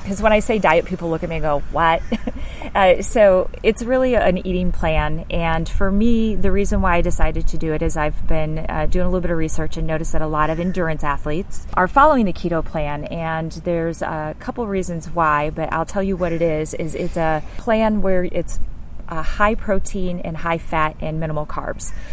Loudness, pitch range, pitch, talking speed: -20 LUFS, 155-195 Hz, 170 Hz, 220 wpm